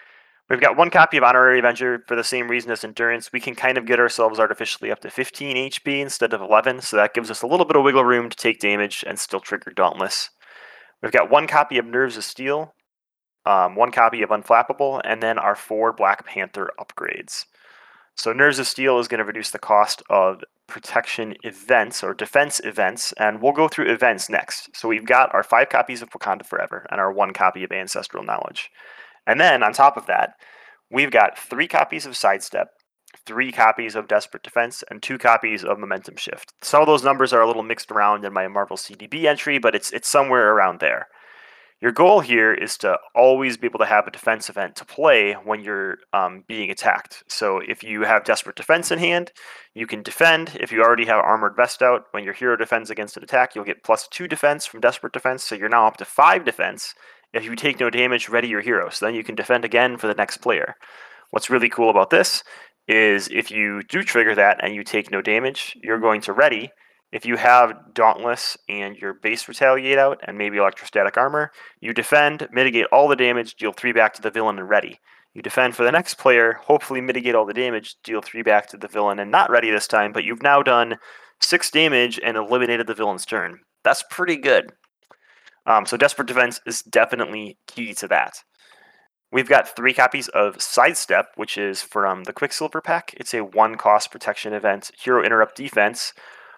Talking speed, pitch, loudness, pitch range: 210 wpm, 120 Hz, -19 LUFS, 110-135 Hz